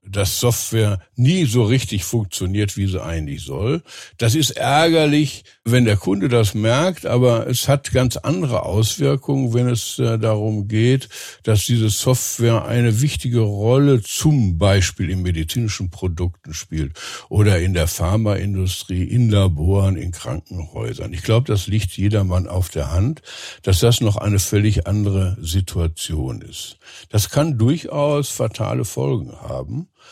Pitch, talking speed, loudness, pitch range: 110 Hz, 140 wpm, -19 LUFS, 95-125 Hz